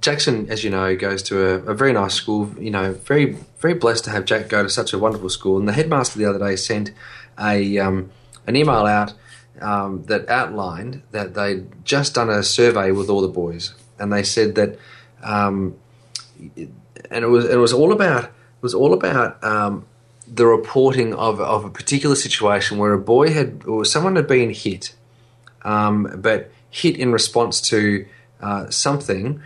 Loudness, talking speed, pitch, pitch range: -19 LUFS, 185 wpm, 110 Hz, 100-120 Hz